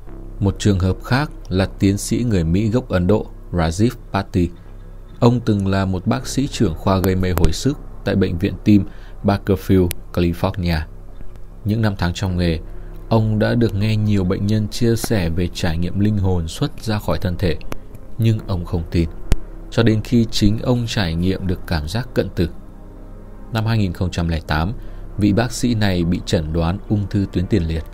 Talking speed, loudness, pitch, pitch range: 185 wpm, -20 LUFS, 100 Hz, 90-110 Hz